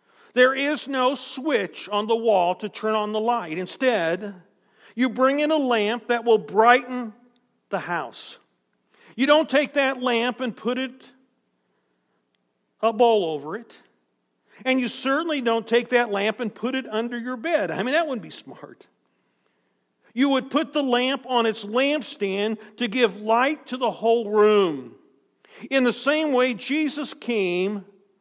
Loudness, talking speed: -23 LUFS, 160 wpm